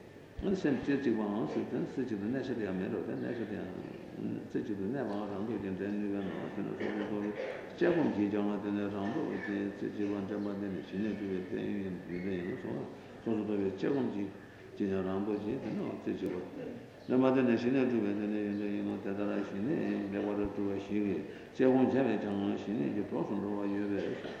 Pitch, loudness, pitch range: 100 Hz, -35 LUFS, 100-105 Hz